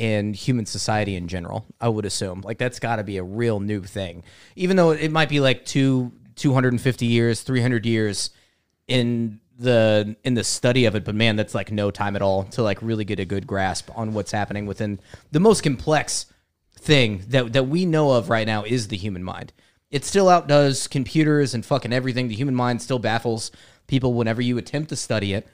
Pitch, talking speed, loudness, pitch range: 115 Hz, 205 wpm, -22 LUFS, 105-130 Hz